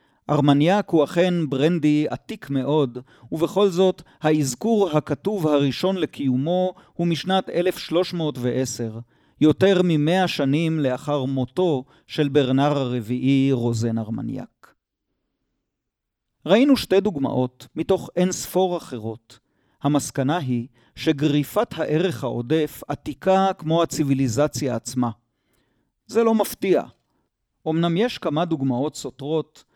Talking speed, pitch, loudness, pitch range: 100 wpm, 150 Hz, -22 LUFS, 130-175 Hz